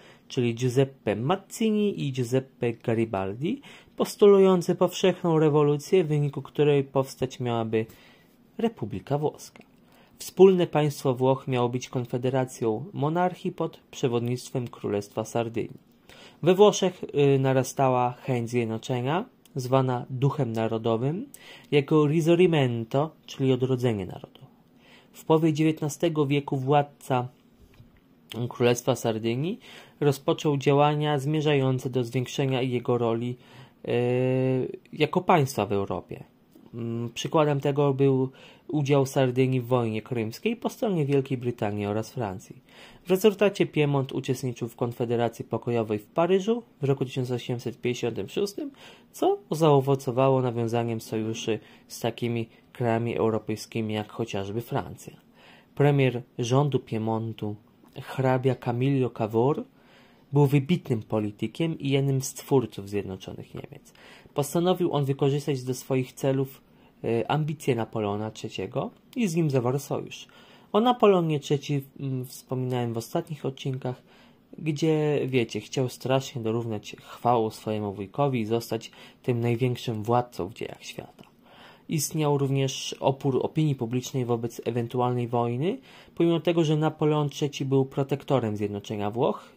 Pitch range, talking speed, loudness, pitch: 120-150 Hz, 110 wpm, -26 LUFS, 130 Hz